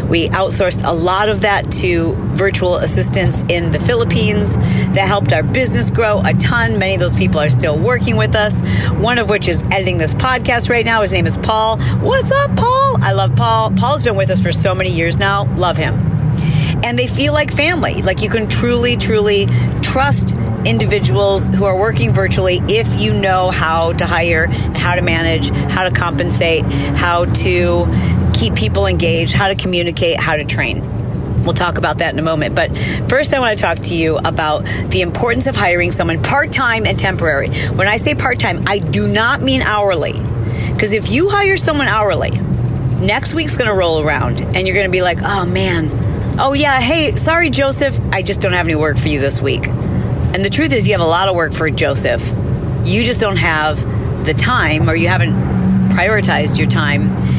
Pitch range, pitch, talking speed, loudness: 95-150 Hz, 115 Hz, 200 wpm, -14 LUFS